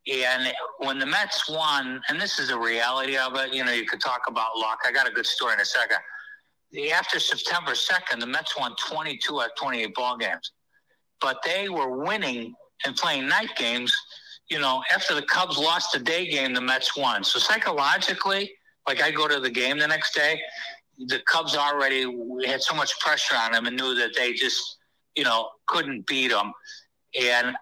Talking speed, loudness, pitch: 195 wpm, -24 LUFS, 135 Hz